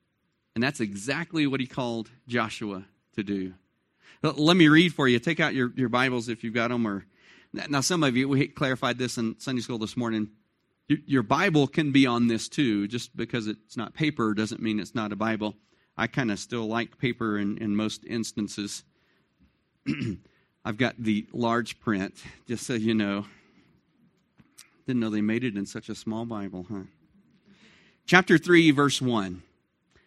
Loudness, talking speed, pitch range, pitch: -26 LUFS, 175 wpm, 110-135 Hz, 115 Hz